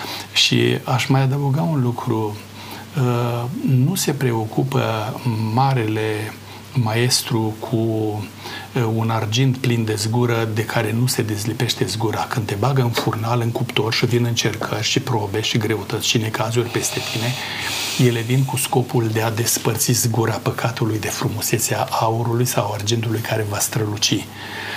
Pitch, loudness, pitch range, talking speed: 115 Hz, -20 LUFS, 110-125 Hz, 140 wpm